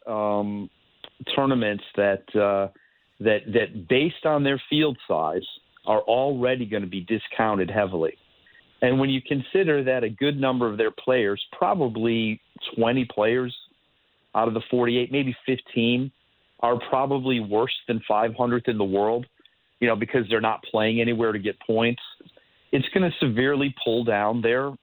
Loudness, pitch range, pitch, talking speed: -24 LUFS, 110-130 Hz, 120 Hz, 150 wpm